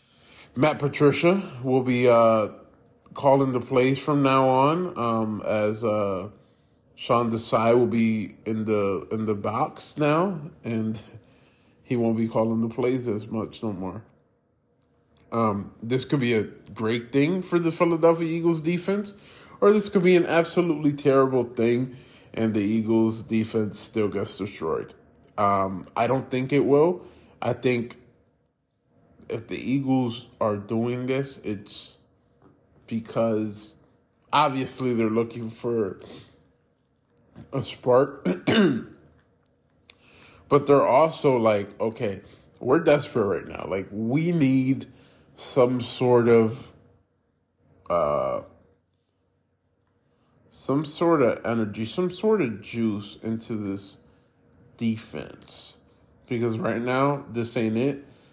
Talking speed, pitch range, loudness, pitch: 120 wpm, 110-135 Hz, -24 LUFS, 120 Hz